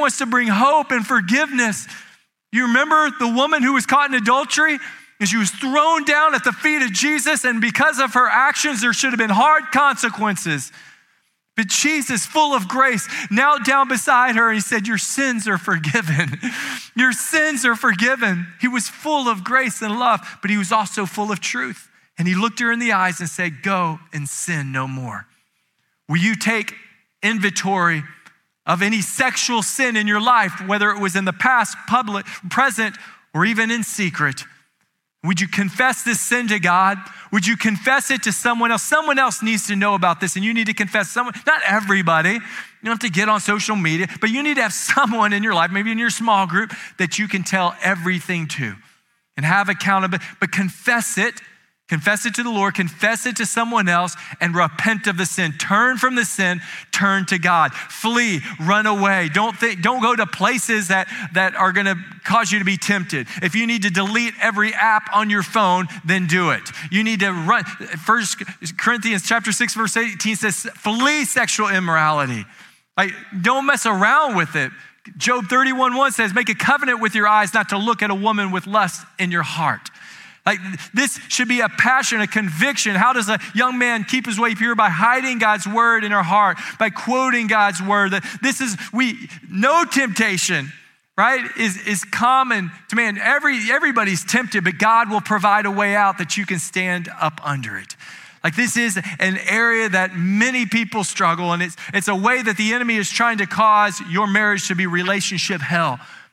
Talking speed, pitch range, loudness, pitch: 195 wpm, 190-240 Hz, -18 LUFS, 215 Hz